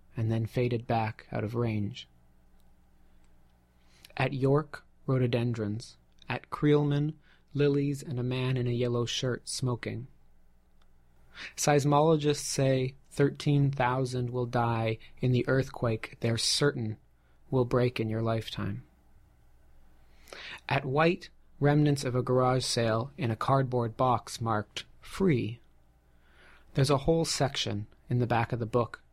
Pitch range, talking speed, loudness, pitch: 100-135 Hz, 120 wpm, -29 LUFS, 120 Hz